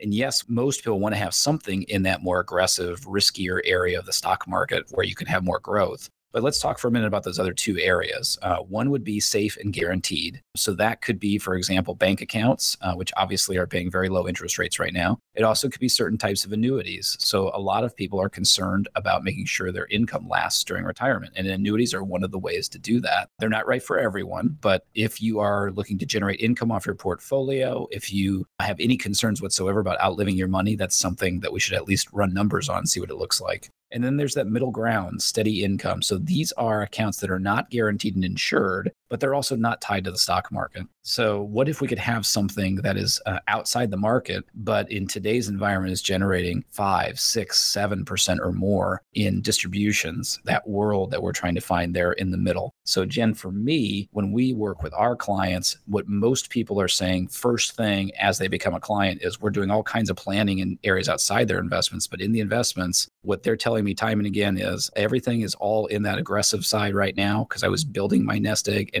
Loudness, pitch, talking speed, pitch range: -24 LUFS, 105 Hz, 230 wpm, 95-115 Hz